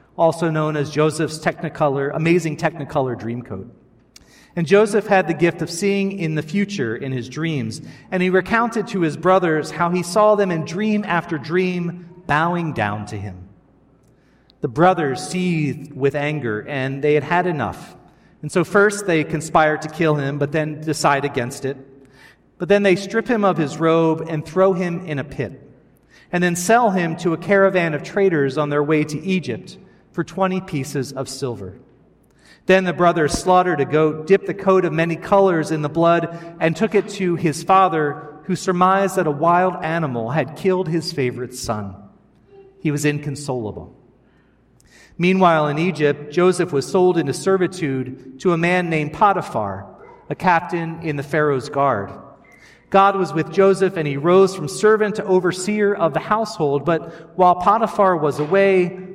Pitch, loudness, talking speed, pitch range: 165 Hz, -19 LUFS, 170 wpm, 145-185 Hz